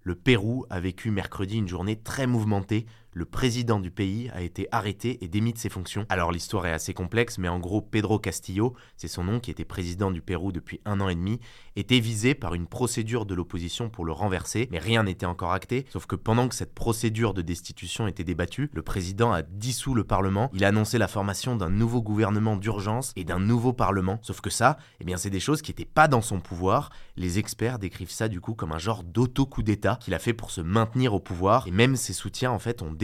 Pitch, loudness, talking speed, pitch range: 105 Hz, -27 LUFS, 230 wpm, 95-115 Hz